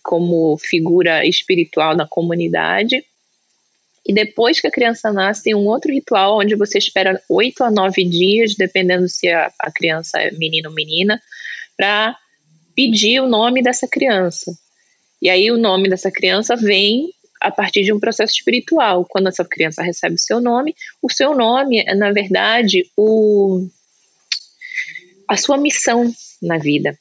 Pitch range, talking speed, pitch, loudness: 180-235 Hz, 150 wpm, 205 Hz, -15 LUFS